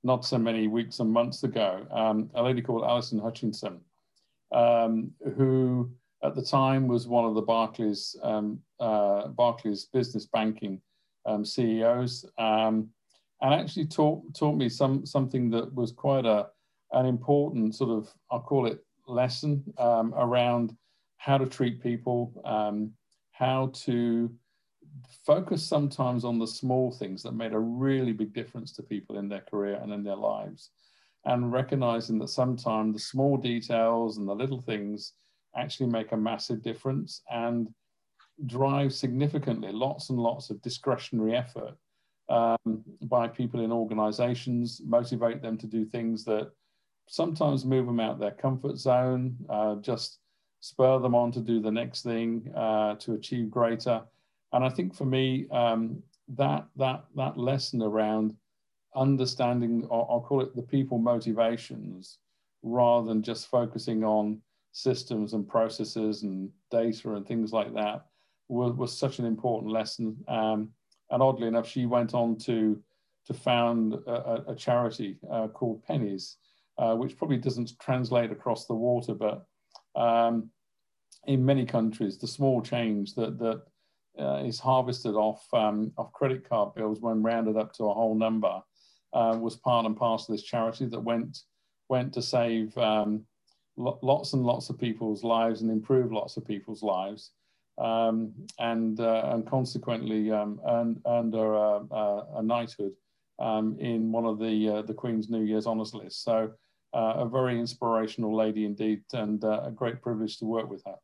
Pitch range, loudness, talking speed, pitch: 110-125 Hz, -29 LUFS, 160 wpm, 115 Hz